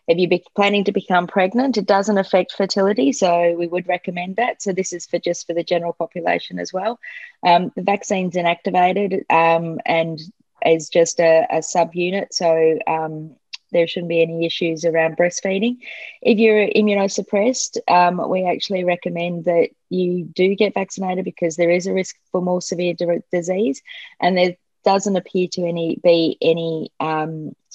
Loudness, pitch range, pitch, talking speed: -19 LUFS, 170-195 Hz, 180 Hz, 165 wpm